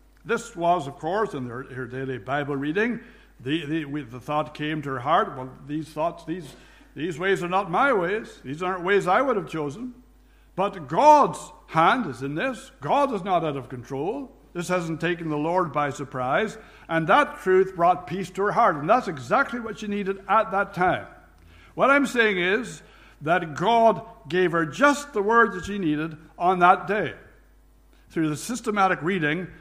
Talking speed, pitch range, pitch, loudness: 185 wpm, 150-205 Hz, 175 Hz, -24 LUFS